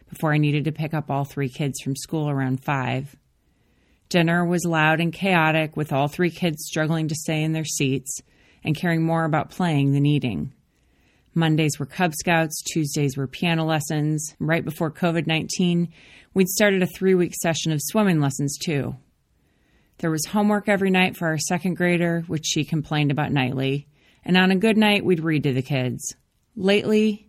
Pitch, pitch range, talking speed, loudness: 160 Hz, 145-175 Hz, 180 wpm, -22 LUFS